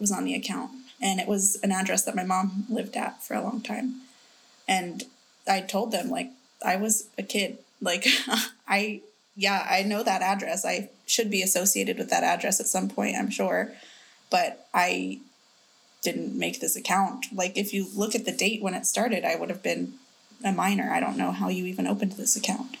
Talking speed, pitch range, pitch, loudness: 205 wpm, 190-240 Hz, 205 Hz, -26 LUFS